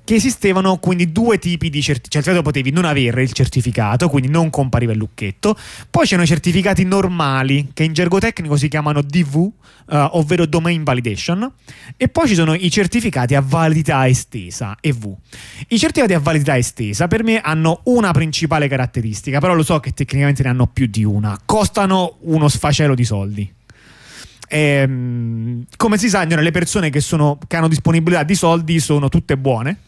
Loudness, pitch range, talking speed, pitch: -16 LUFS, 130-175 Hz, 175 wpm, 155 Hz